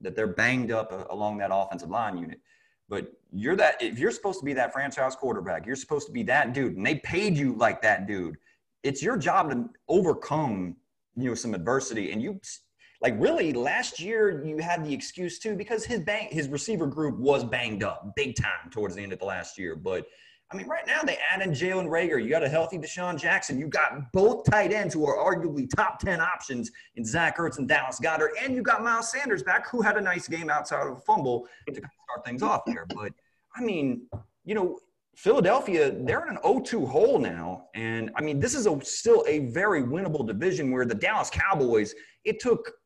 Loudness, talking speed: -27 LUFS, 215 wpm